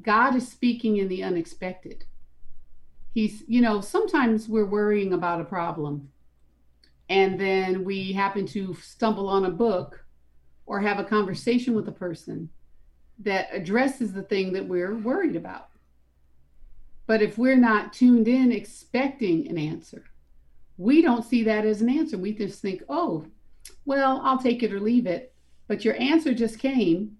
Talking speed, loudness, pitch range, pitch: 155 wpm, -24 LUFS, 170-235 Hz, 205 Hz